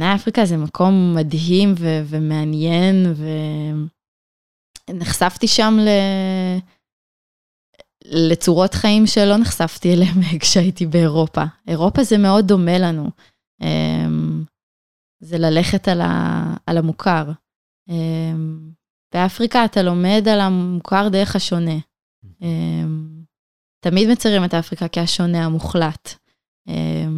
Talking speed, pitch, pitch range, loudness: 90 wpm, 170 Hz, 155-190 Hz, -17 LUFS